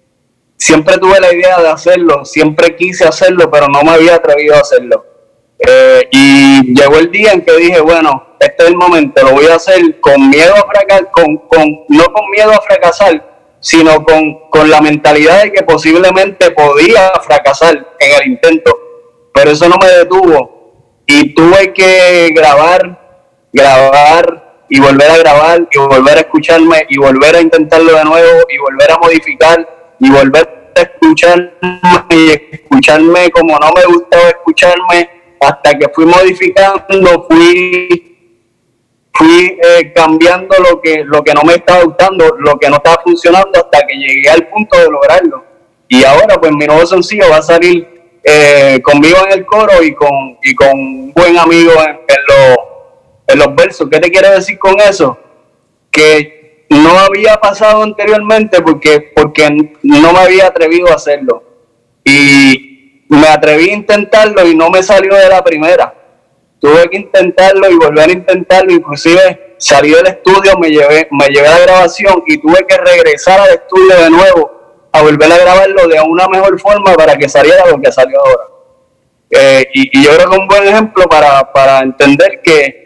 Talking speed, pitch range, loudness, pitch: 170 wpm, 155-210 Hz, -5 LUFS, 175 Hz